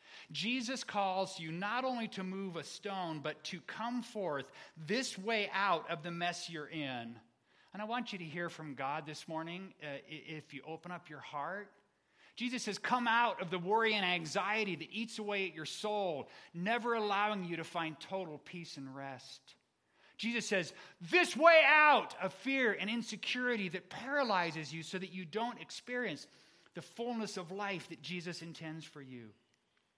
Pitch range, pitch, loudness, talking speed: 160-220 Hz, 190 Hz, -35 LUFS, 175 wpm